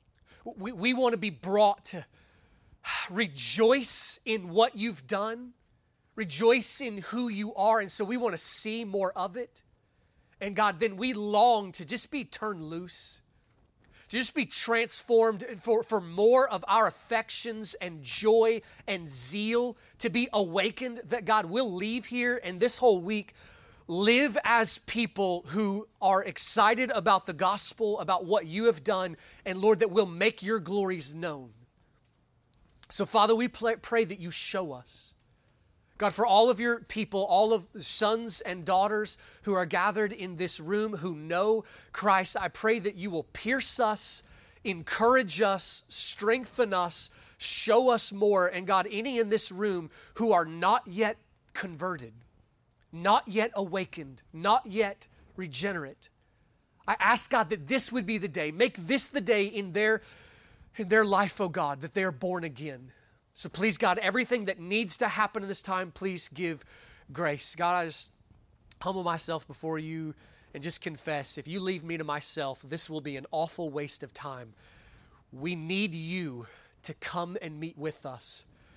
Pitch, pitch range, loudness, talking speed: 200 Hz, 170-225 Hz, -28 LUFS, 165 wpm